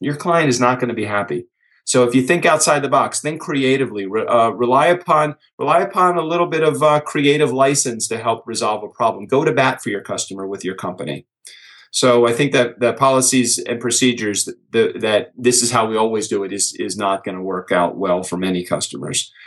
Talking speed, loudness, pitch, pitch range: 220 wpm, -17 LUFS, 125 Hz, 105-145 Hz